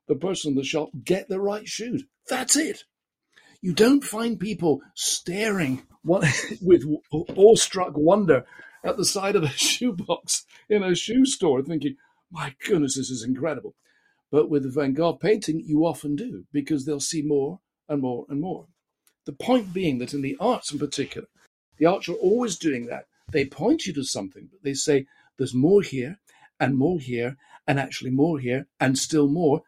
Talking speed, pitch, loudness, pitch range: 180 wpm, 155 Hz, -24 LUFS, 140-195 Hz